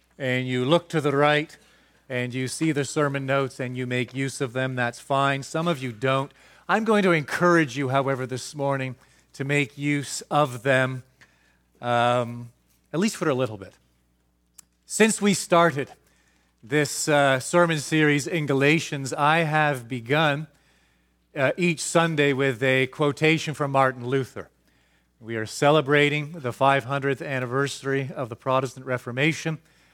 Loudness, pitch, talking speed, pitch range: -23 LUFS, 135 Hz, 150 wpm, 125-150 Hz